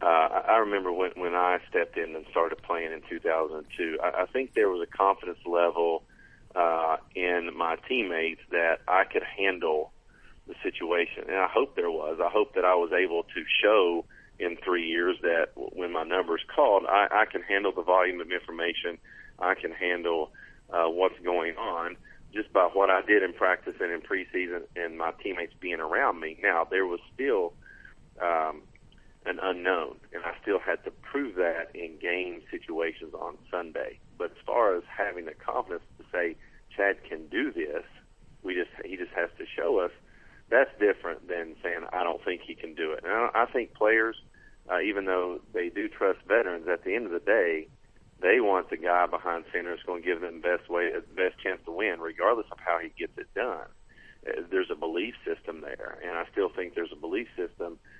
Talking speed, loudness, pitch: 200 wpm, -29 LUFS, 380 Hz